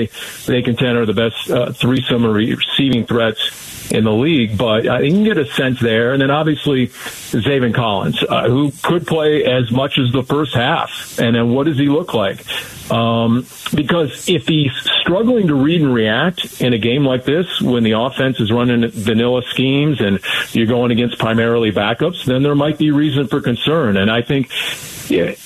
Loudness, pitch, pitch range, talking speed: -15 LUFS, 125 Hz, 115-145 Hz, 190 wpm